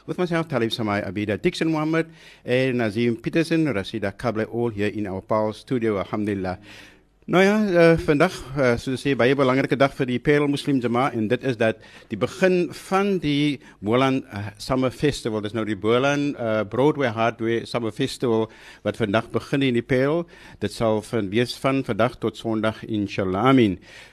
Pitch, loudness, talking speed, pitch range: 120 Hz, -23 LUFS, 180 wpm, 110-145 Hz